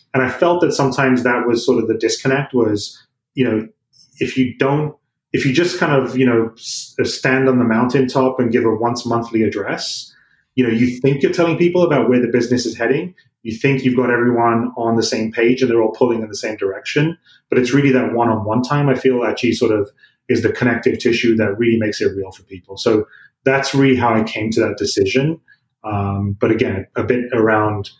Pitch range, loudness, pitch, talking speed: 115-135 Hz, -17 LUFS, 125 Hz, 215 wpm